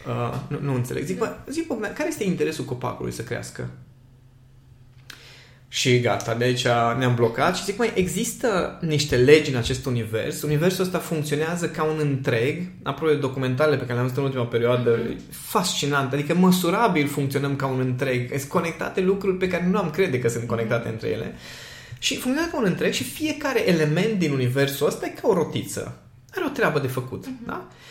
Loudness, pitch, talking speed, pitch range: -23 LUFS, 140 Hz, 185 wpm, 125-175 Hz